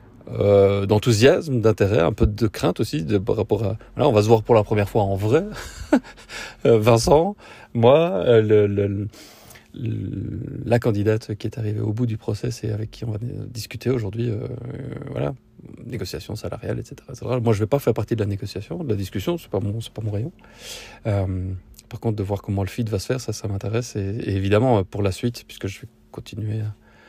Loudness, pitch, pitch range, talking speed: -22 LUFS, 110 Hz, 100-120 Hz, 210 wpm